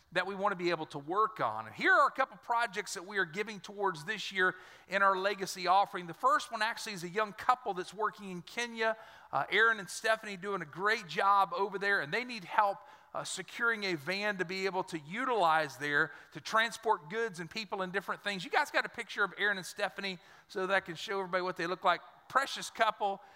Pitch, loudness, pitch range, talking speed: 200 Hz, -33 LUFS, 185-220 Hz, 235 wpm